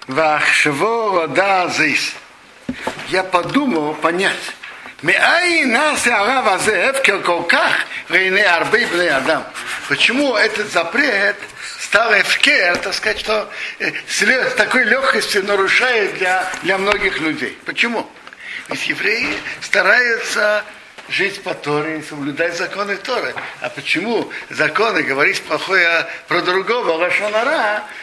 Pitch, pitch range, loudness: 190 Hz, 170-220 Hz, -16 LUFS